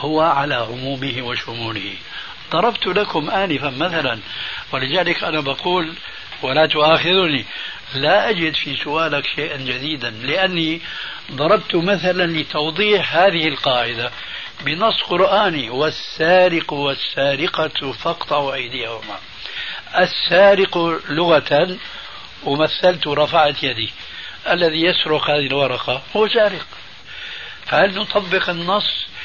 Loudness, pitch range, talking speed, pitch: -18 LUFS, 140-180 Hz, 90 wpm, 155 Hz